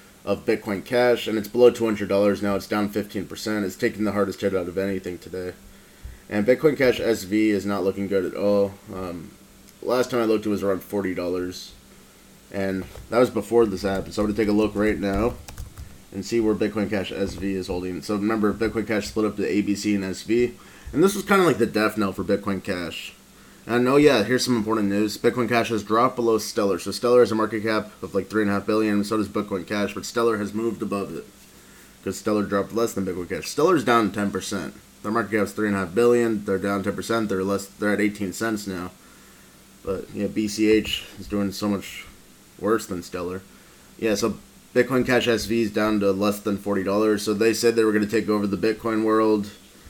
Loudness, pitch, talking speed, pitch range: -23 LUFS, 105 Hz, 220 wpm, 100-110 Hz